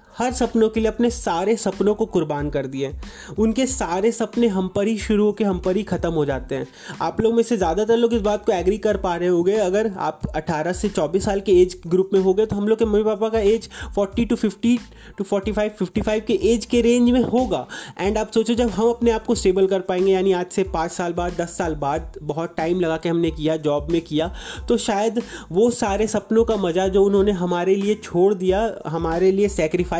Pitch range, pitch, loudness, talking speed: 180-225 Hz, 200 Hz, -21 LUFS, 230 wpm